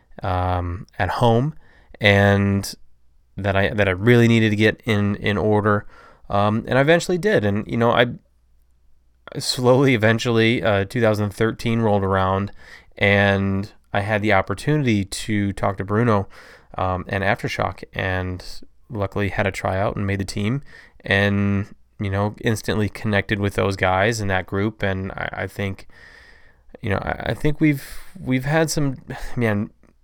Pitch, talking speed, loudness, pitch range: 105 Hz, 150 wpm, -20 LUFS, 95-115 Hz